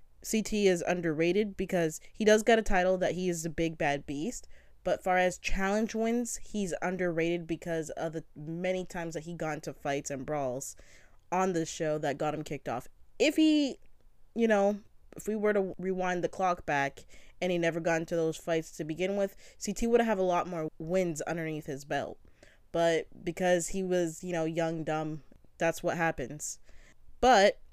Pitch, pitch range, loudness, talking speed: 170 Hz, 160-190 Hz, -31 LUFS, 190 wpm